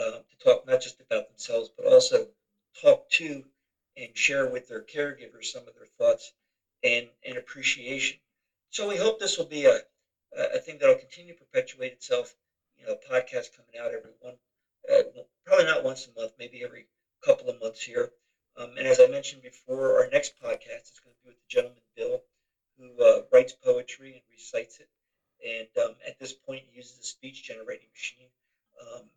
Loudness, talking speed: -26 LUFS, 195 wpm